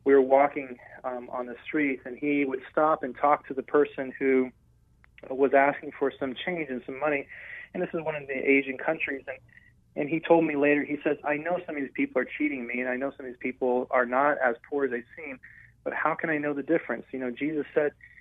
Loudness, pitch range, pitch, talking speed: -28 LUFS, 130-150 Hz, 140 Hz, 245 wpm